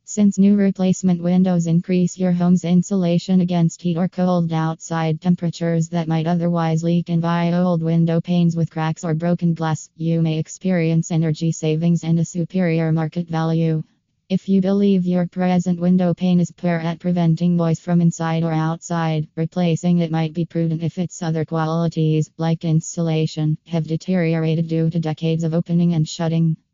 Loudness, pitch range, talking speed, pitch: -19 LUFS, 160-175 Hz, 165 wpm, 165 Hz